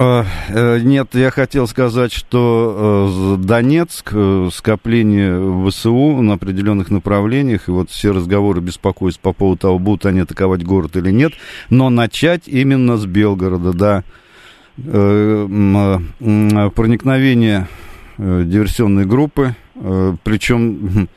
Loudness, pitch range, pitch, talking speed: -14 LUFS, 95-120 Hz, 105 Hz, 100 wpm